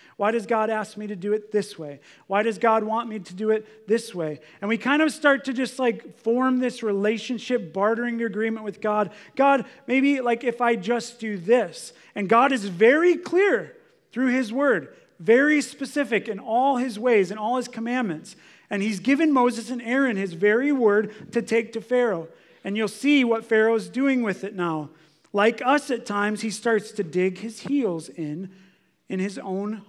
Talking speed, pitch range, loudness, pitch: 195 wpm, 205-250 Hz, -23 LUFS, 225 Hz